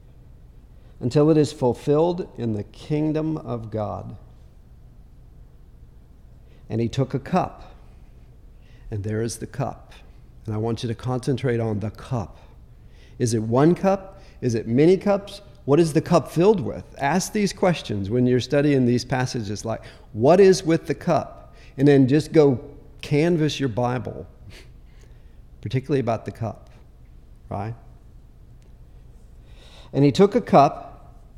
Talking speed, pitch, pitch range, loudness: 140 wpm, 125 Hz, 105-150 Hz, -22 LUFS